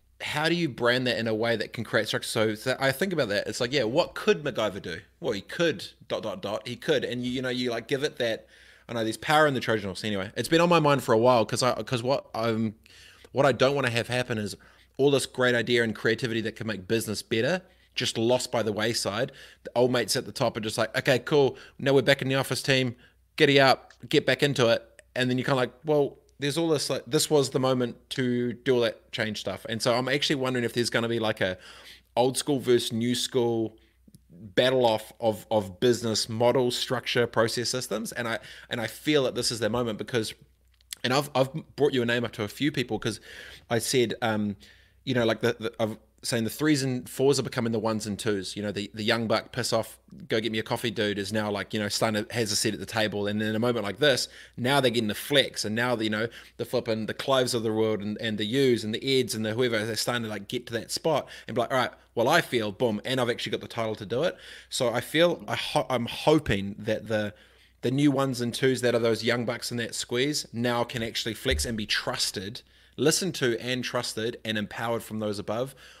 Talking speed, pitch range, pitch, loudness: 260 wpm, 110-130 Hz, 120 Hz, -27 LUFS